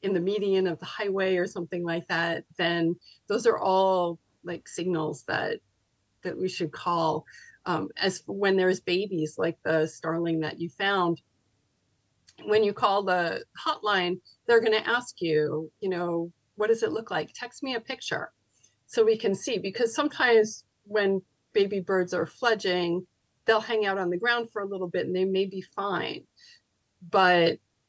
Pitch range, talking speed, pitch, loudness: 170-205 Hz, 170 wpm, 185 Hz, -27 LUFS